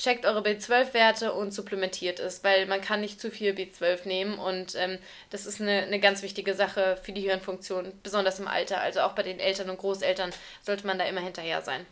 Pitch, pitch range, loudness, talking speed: 195 Hz, 185-205 Hz, -28 LUFS, 210 wpm